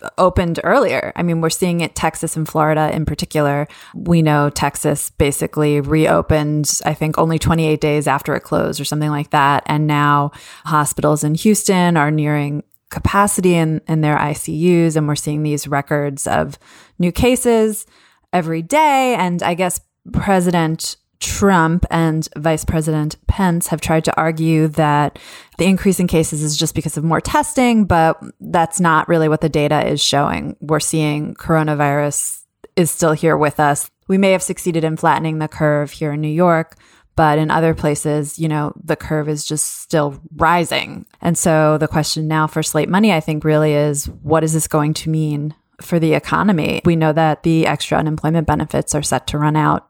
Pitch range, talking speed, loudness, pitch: 150-170 Hz, 180 wpm, -16 LUFS, 155 Hz